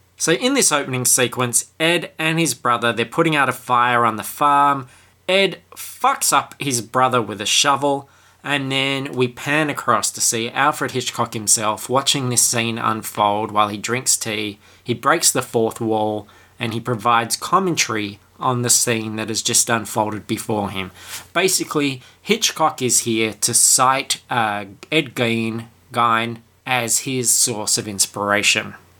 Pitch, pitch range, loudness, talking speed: 120 Hz, 110-135 Hz, -18 LUFS, 155 wpm